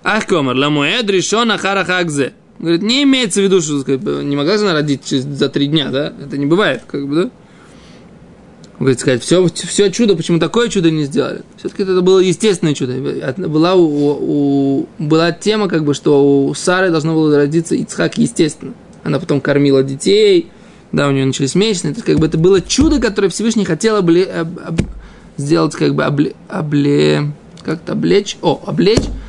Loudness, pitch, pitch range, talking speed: -14 LUFS, 165 Hz, 145-195 Hz, 180 wpm